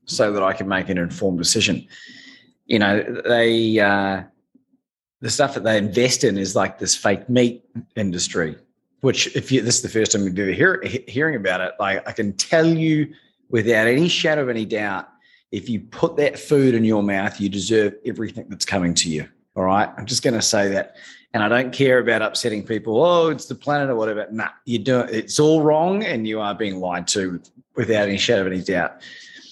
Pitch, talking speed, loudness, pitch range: 115 Hz, 210 wpm, -20 LUFS, 100-130 Hz